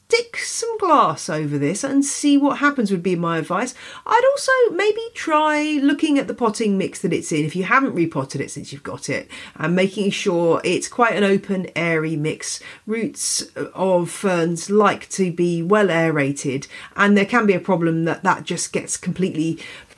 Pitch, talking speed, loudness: 195 Hz, 190 wpm, -20 LUFS